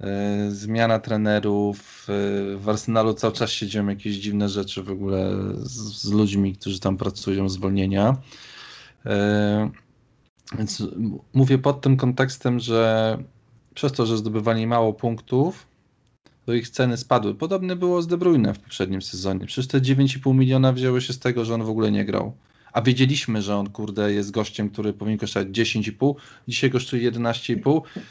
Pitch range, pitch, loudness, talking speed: 100-125 Hz, 110 Hz, -23 LUFS, 150 wpm